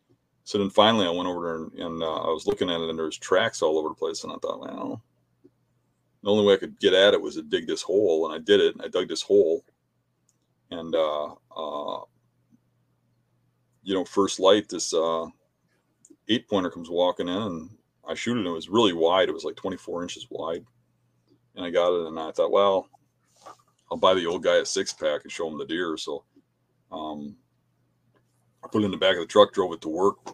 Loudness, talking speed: -25 LUFS, 225 wpm